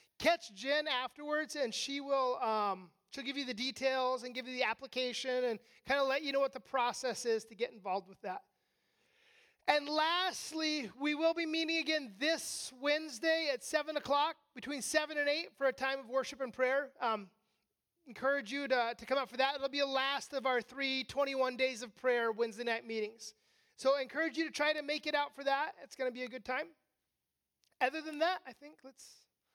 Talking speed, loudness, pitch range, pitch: 210 wpm, -35 LUFS, 250-295 Hz, 270 Hz